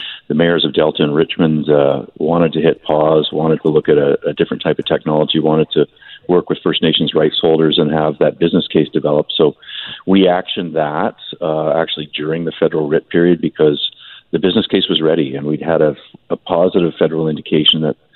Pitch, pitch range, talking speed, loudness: 80 Hz, 75-80 Hz, 200 wpm, -15 LUFS